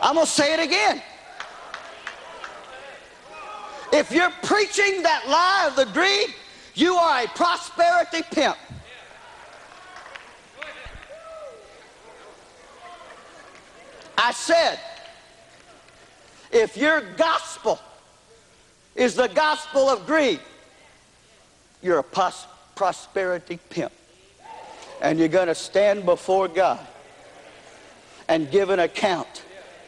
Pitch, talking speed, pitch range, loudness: 320 Hz, 90 wpm, 250-350 Hz, -21 LUFS